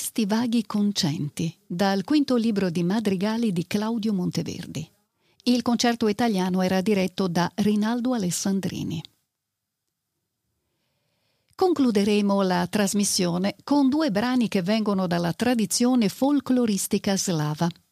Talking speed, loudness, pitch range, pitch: 105 wpm, -24 LUFS, 185-235 Hz, 205 Hz